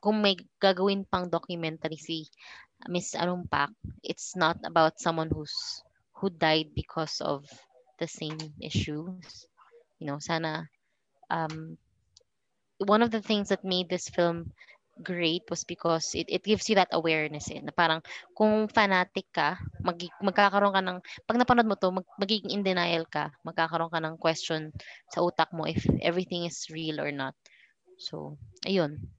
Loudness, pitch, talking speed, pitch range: -29 LUFS, 170 Hz, 155 wpm, 160-195 Hz